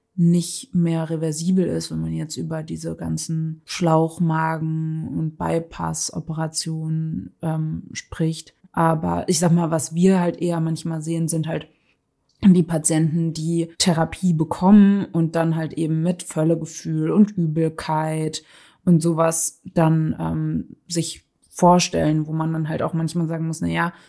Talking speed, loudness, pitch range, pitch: 135 wpm, -21 LUFS, 160-170 Hz, 160 Hz